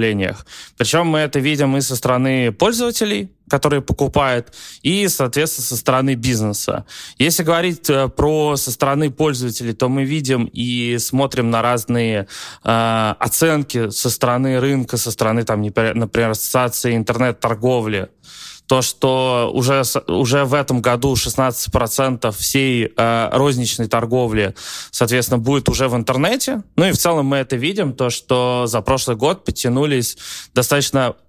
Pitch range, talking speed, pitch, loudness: 120-140 Hz, 135 wpm, 125 Hz, -17 LUFS